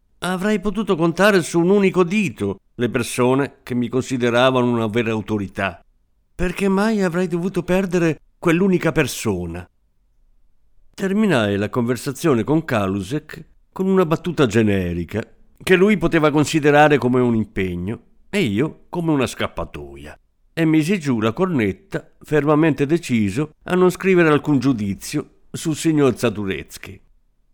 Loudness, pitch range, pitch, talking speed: -19 LUFS, 110-175 Hz, 140 Hz, 125 wpm